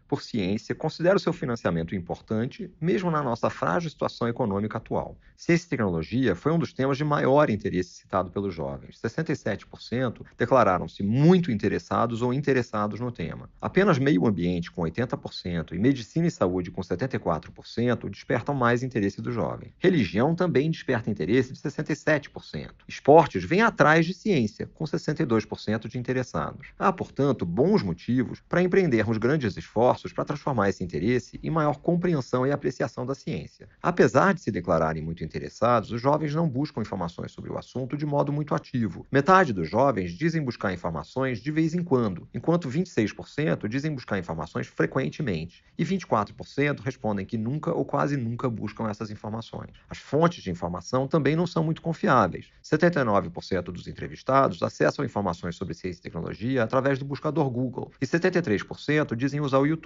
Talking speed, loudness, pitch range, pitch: 160 wpm, -26 LUFS, 105-155 Hz, 130 Hz